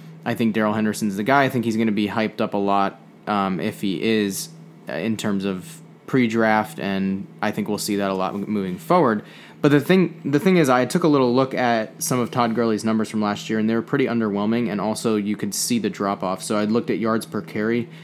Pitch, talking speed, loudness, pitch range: 110 Hz, 245 wpm, -21 LUFS, 105-125 Hz